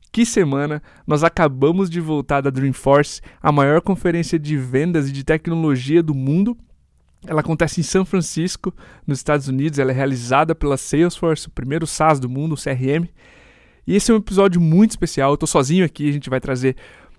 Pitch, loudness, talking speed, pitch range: 155 Hz, -18 LUFS, 185 wpm, 140-170 Hz